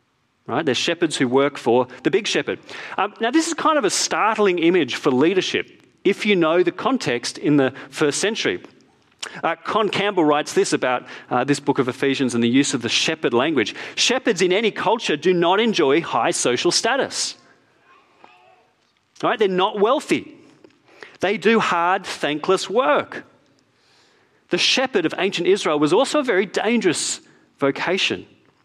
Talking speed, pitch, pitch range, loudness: 160 wpm, 175 Hz, 140-225 Hz, -20 LUFS